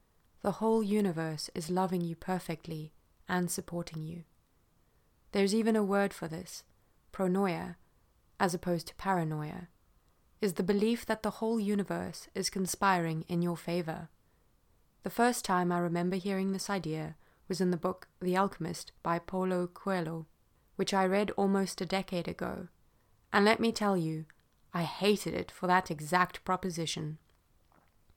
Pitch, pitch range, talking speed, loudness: 180 Hz, 170-195 Hz, 145 wpm, -33 LUFS